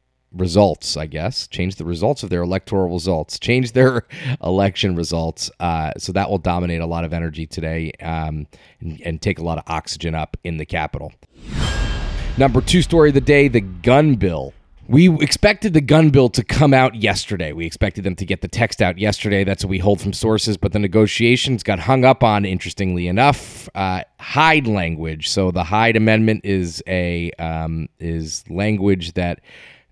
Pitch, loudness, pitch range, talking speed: 95 Hz, -18 LUFS, 85-115 Hz, 185 wpm